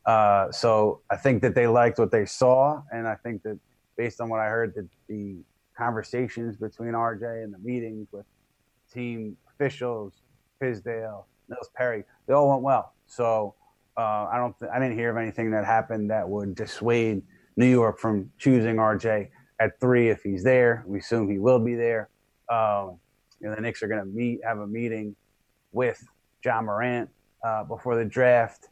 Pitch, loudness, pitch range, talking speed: 115 Hz, -25 LUFS, 110-125 Hz, 180 wpm